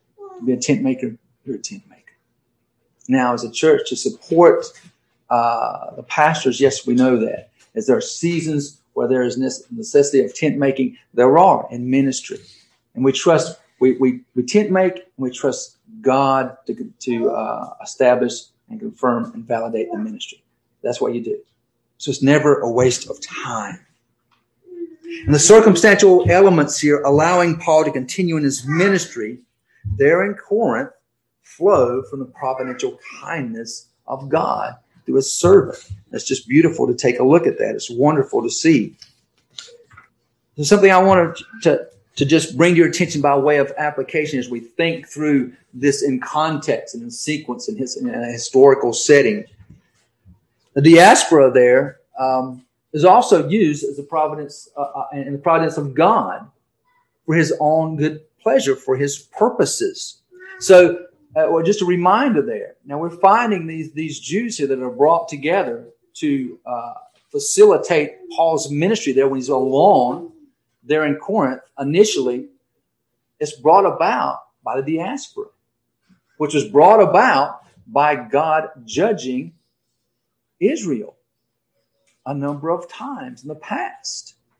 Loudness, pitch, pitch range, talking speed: -17 LUFS, 150 Hz, 130-205 Hz, 150 wpm